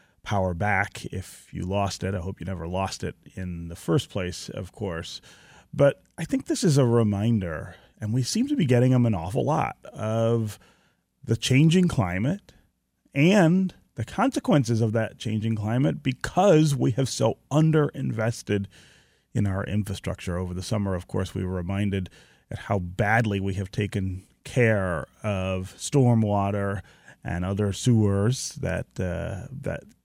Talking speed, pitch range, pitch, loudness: 155 wpm, 95-130 Hz, 105 Hz, -25 LUFS